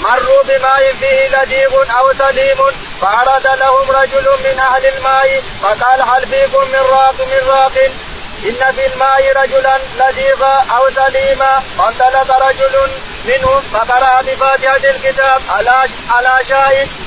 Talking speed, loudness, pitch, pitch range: 115 wpm, -10 LUFS, 270 Hz, 265-270 Hz